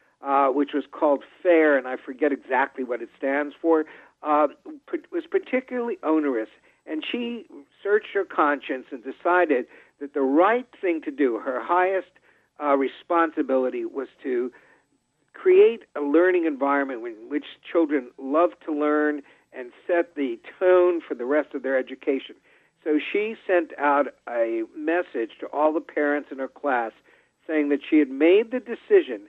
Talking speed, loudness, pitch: 155 wpm, -24 LUFS, 155 Hz